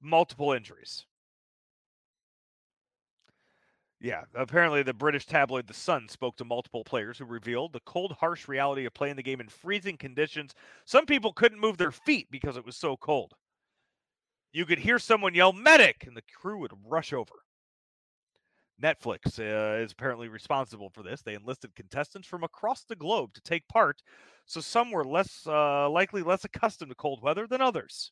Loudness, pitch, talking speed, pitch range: -28 LUFS, 145 Hz, 170 wpm, 125-185 Hz